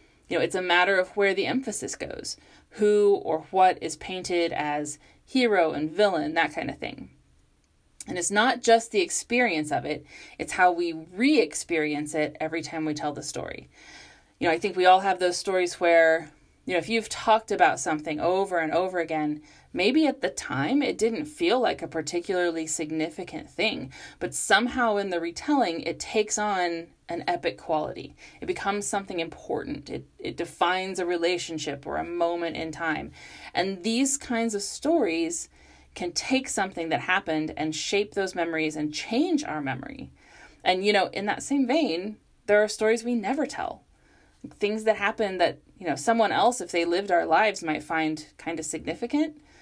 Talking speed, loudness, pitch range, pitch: 180 wpm, -26 LUFS, 165-225 Hz, 185 Hz